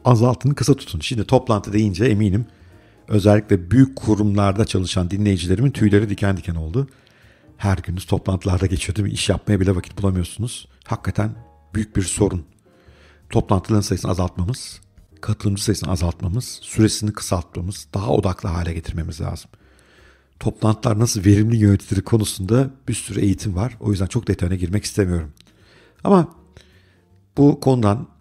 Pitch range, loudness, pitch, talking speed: 95-110 Hz, -20 LUFS, 100 Hz, 130 wpm